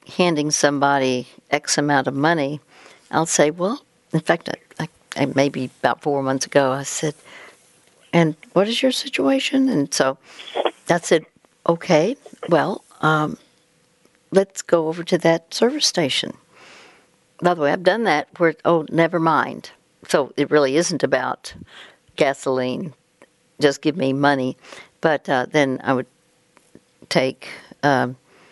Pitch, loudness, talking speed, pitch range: 155 Hz, -20 LUFS, 140 wpm, 140-170 Hz